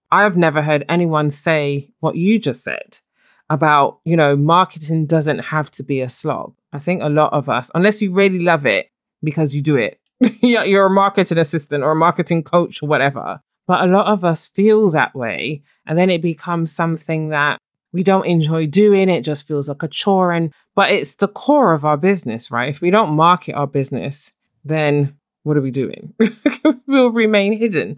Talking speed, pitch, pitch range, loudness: 195 wpm, 165 Hz, 150-195 Hz, -16 LUFS